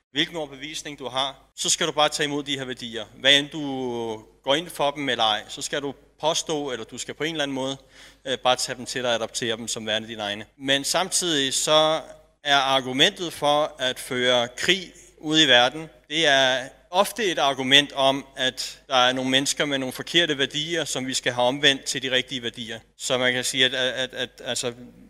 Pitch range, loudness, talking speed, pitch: 125-150 Hz, -22 LUFS, 215 wpm, 135 Hz